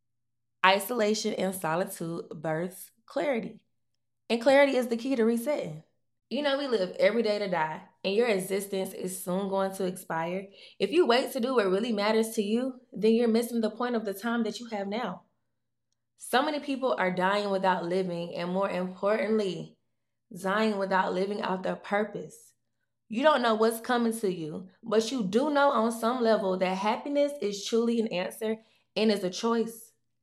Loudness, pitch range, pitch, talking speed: -28 LUFS, 185-230 Hz, 210 Hz, 180 wpm